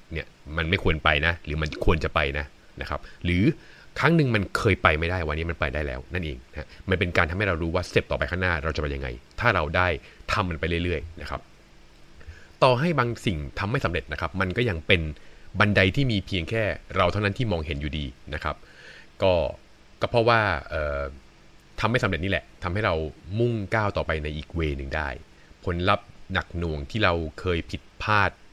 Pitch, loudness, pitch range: 85 Hz, -25 LUFS, 75-100 Hz